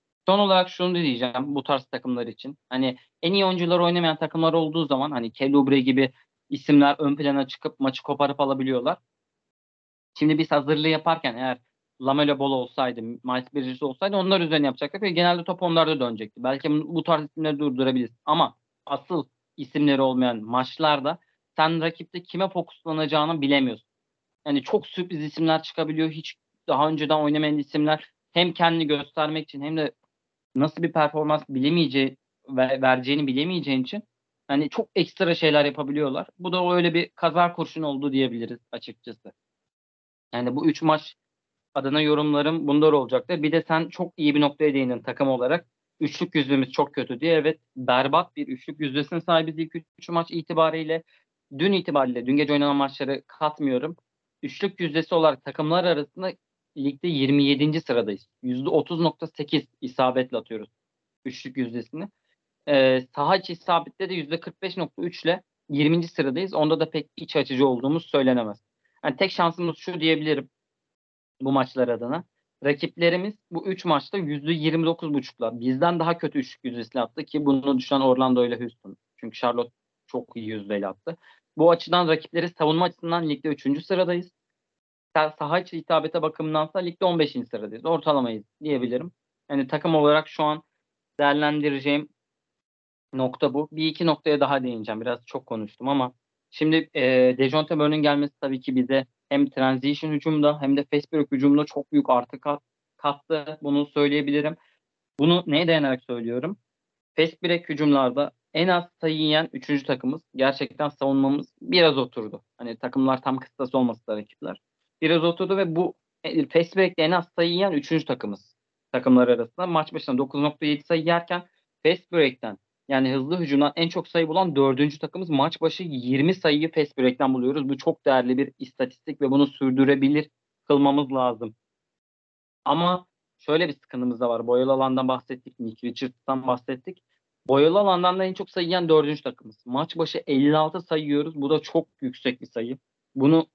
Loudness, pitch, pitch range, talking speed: -24 LUFS, 150 Hz, 135-165 Hz, 150 wpm